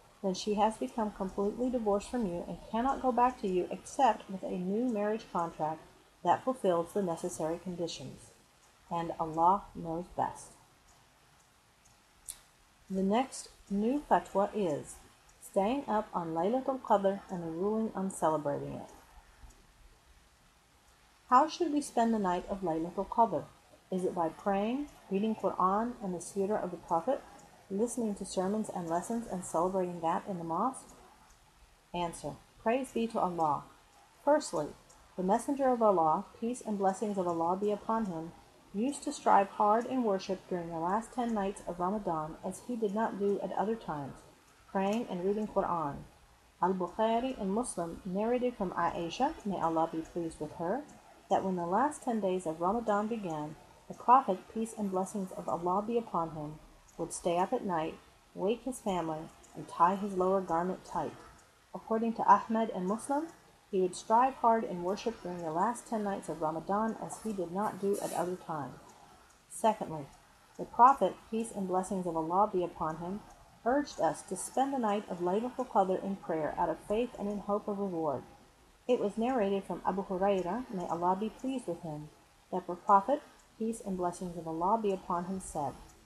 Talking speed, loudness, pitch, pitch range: 170 wpm, -33 LUFS, 195 Hz, 175-225 Hz